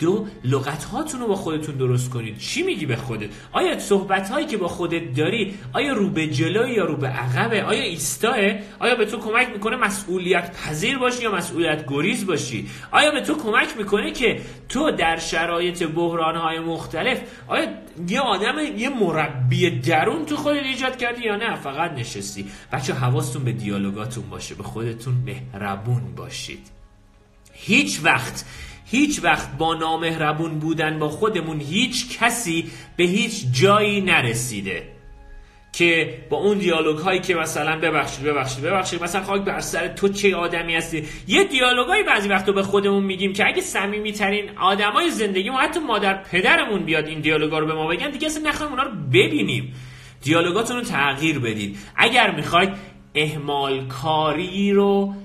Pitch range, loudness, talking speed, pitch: 150-205 Hz, -21 LUFS, 160 wpm, 170 Hz